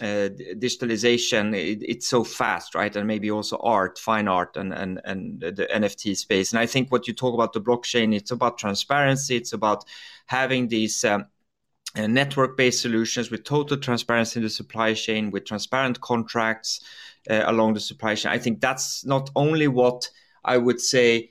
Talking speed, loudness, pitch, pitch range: 175 wpm, -23 LUFS, 115 Hz, 110-125 Hz